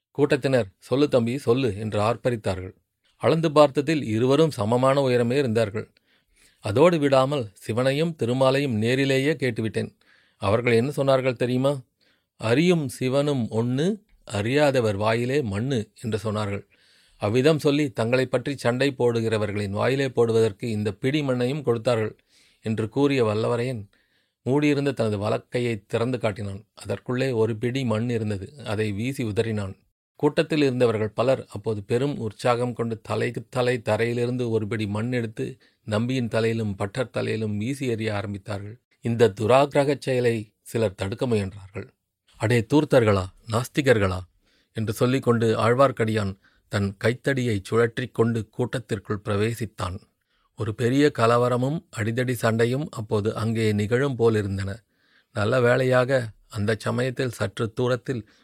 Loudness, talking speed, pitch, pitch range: -24 LUFS, 115 wpm, 115 Hz, 110-130 Hz